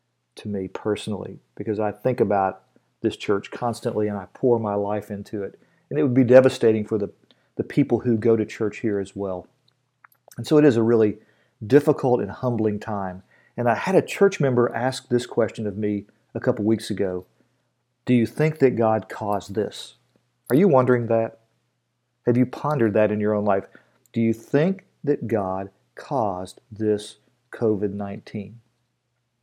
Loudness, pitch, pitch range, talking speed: -23 LUFS, 115 Hz, 105-125 Hz, 175 wpm